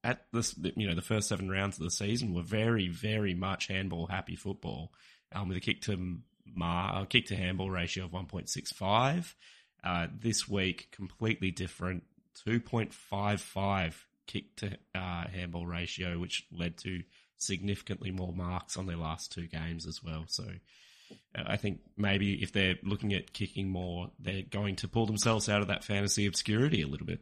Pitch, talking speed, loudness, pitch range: 95 Hz, 185 wpm, -34 LUFS, 90-105 Hz